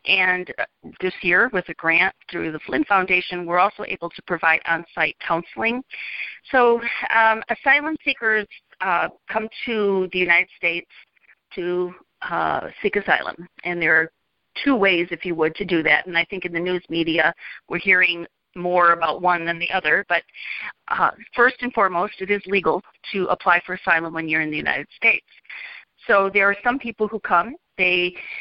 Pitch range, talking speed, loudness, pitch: 170-205 Hz, 175 wpm, -20 LUFS, 180 Hz